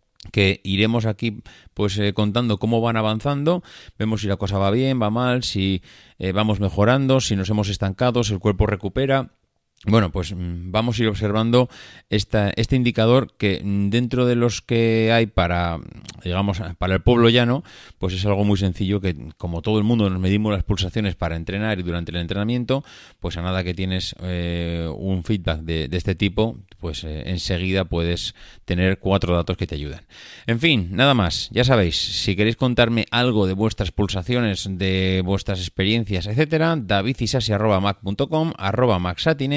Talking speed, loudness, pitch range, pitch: 165 wpm, -21 LUFS, 95-115 Hz, 105 Hz